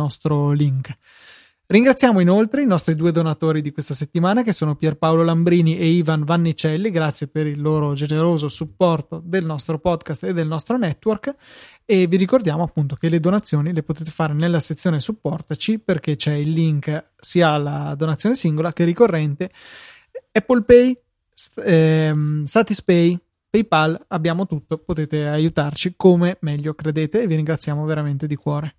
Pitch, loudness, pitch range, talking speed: 160 Hz, -19 LUFS, 155-185 Hz, 150 wpm